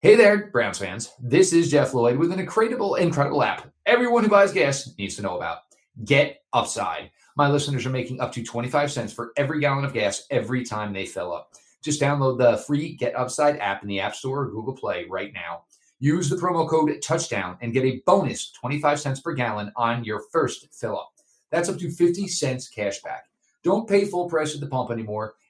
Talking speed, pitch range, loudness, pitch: 210 wpm, 120-160 Hz, -23 LUFS, 140 Hz